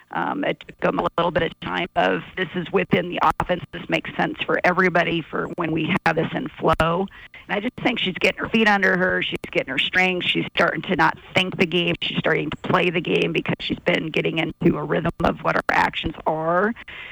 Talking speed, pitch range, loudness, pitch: 230 wpm, 170-190 Hz, -21 LUFS, 180 Hz